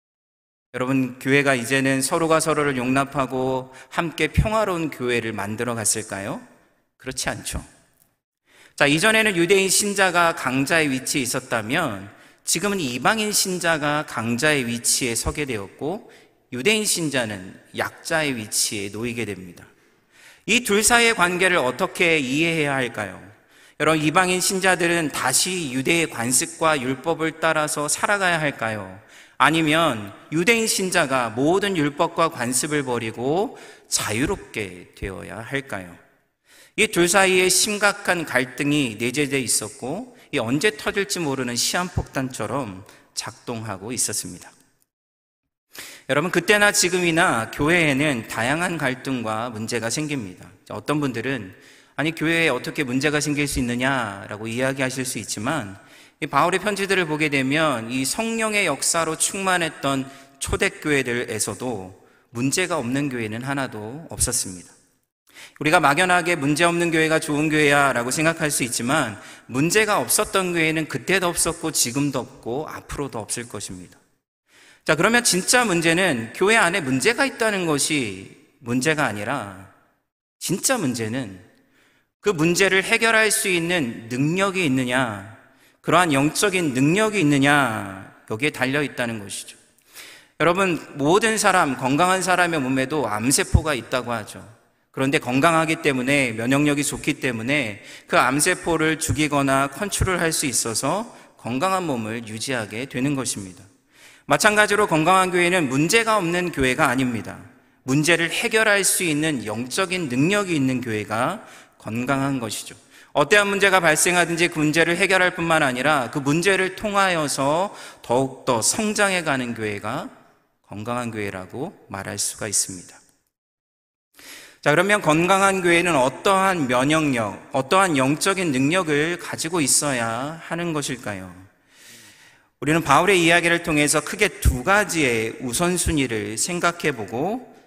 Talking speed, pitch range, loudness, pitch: 305 characters per minute, 125-175 Hz, -21 LUFS, 145 Hz